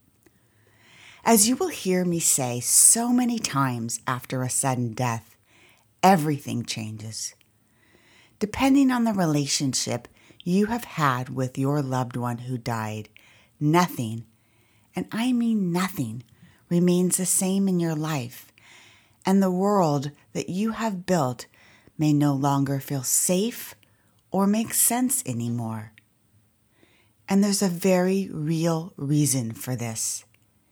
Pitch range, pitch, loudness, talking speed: 115-180 Hz, 135 Hz, -23 LUFS, 125 wpm